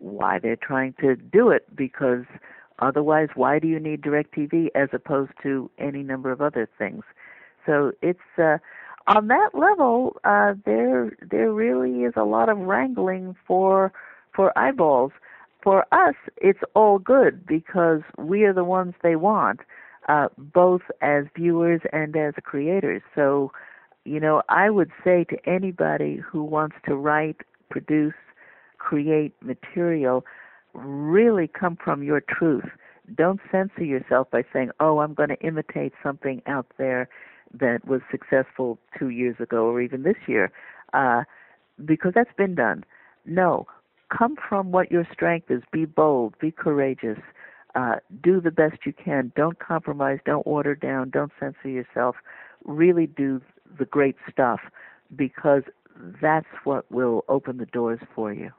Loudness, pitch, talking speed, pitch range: -23 LUFS, 150 Hz, 150 wpm, 130-175 Hz